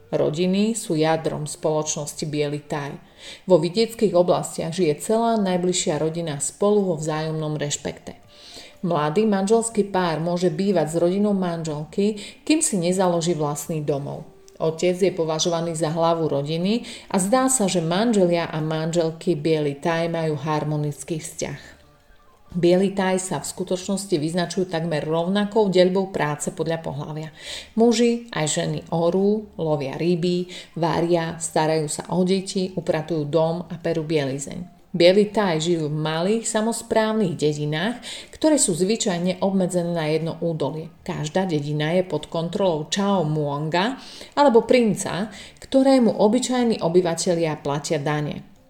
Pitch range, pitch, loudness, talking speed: 160-195 Hz, 175 Hz, -22 LUFS, 125 wpm